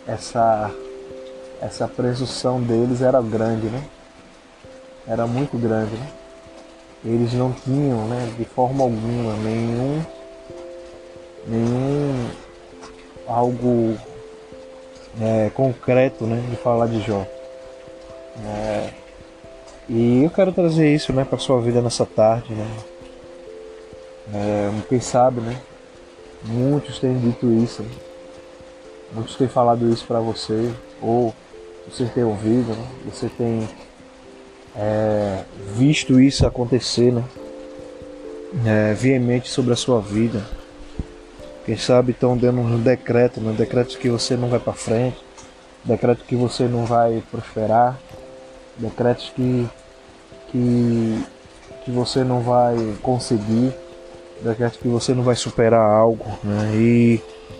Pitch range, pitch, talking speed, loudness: 105-125 Hz, 115 Hz, 115 wpm, -20 LUFS